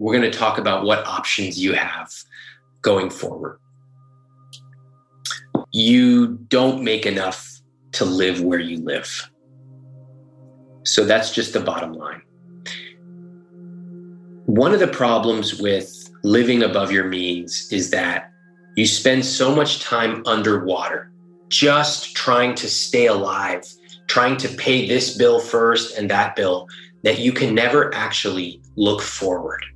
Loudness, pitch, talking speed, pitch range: -19 LUFS, 130 Hz, 130 wpm, 110-135 Hz